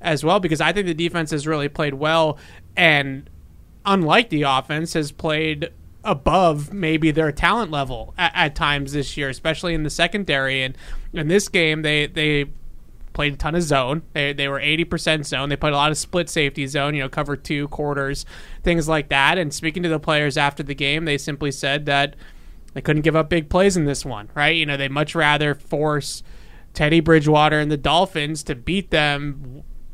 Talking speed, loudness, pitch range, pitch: 200 wpm, -20 LUFS, 145-160 Hz, 150 Hz